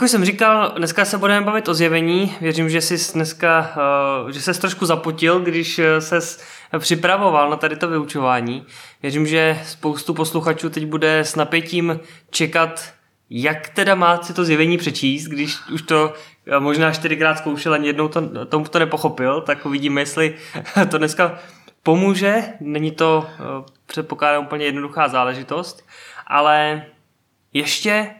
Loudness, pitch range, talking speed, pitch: -18 LUFS, 150-170 Hz, 140 wpm, 160 Hz